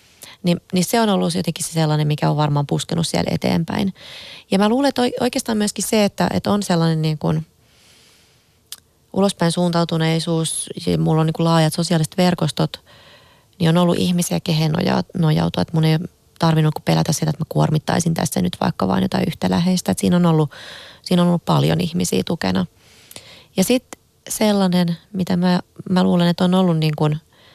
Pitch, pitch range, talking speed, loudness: 170 Hz, 160-185 Hz, 170 wpm, -19 LUFS